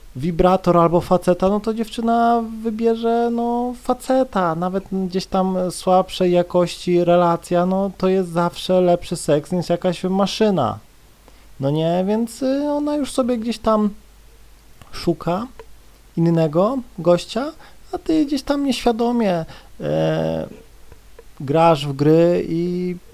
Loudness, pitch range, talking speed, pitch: -19 LUFS, 175-230 Hz, 115 wpm, 185 Hz